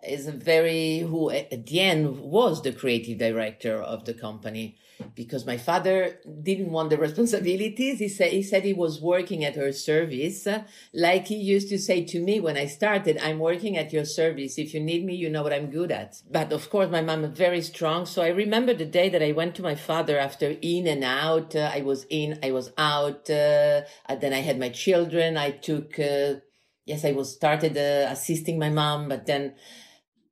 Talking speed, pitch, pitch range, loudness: 210 wpm, 155 Hz, 140-175 Hz, -25 LUFS